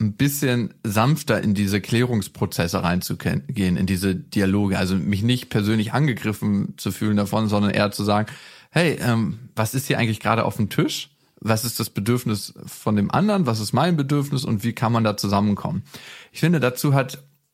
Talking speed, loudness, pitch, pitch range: 180 wpm, -22 LUFS, 110 Hz, 105-130 Hz